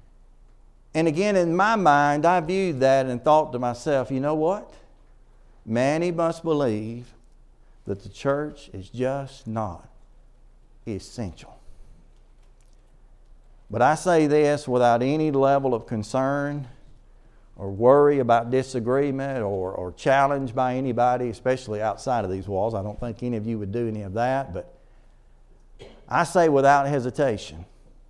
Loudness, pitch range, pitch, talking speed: -23 LUFS, 115-145 Hz, 130 Hz, 135 wpm